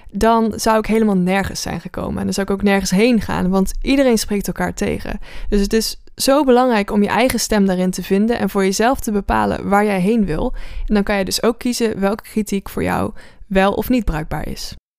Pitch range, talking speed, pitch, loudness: 195-225 Hz, 230 wpm, 205 Hz, -17 LUFS